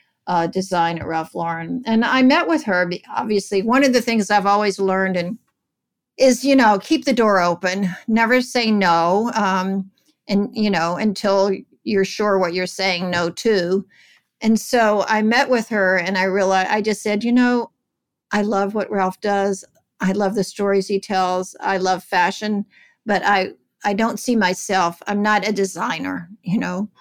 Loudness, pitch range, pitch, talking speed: -19 LUFS, 185-220 Hz, 200 Hz, 180 wpm